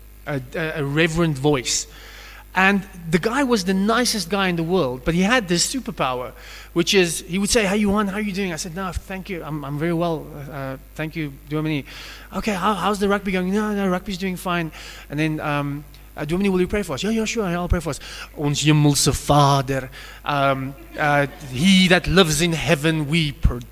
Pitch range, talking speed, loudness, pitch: 145-195 Hz, 205 wpm, -21 LUFS, 170 Hz